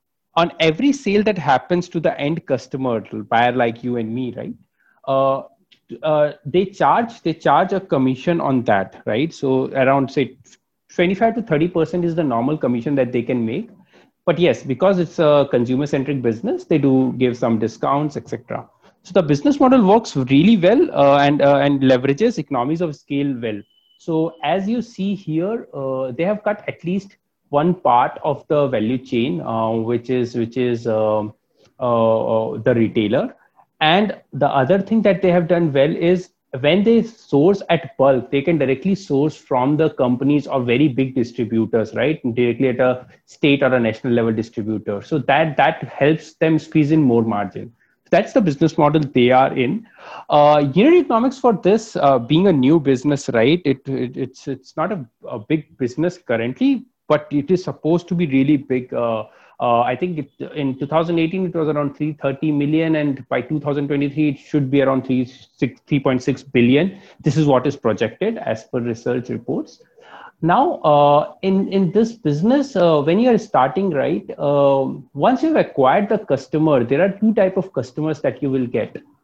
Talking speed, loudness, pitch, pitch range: 180 wpm, -18 LUFS, 145 Hz, 130-175 Hz